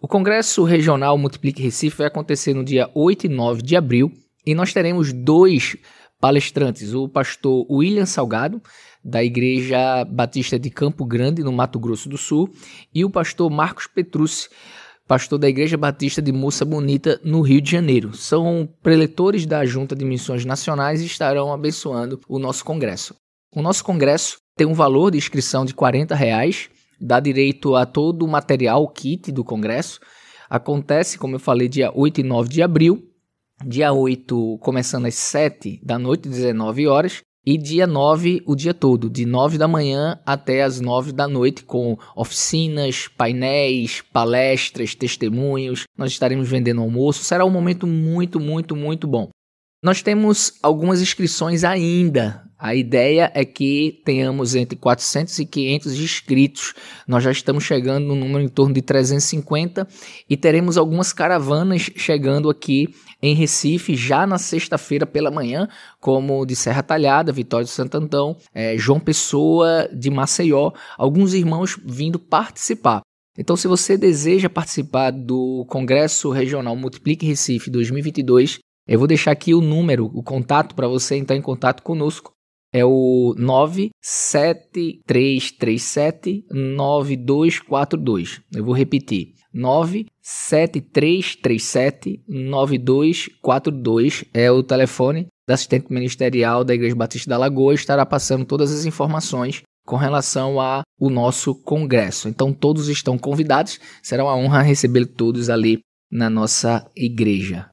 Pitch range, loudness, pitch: 130-155 Hz, -19 LUFS, 140 Hz